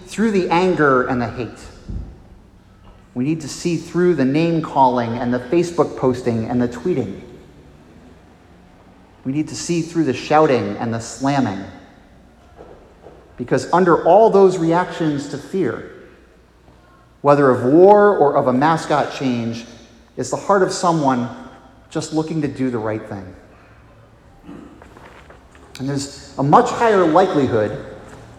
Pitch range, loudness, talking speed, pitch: 105-155 Hz, -17 LUFS, 135 wpm, 130 Hz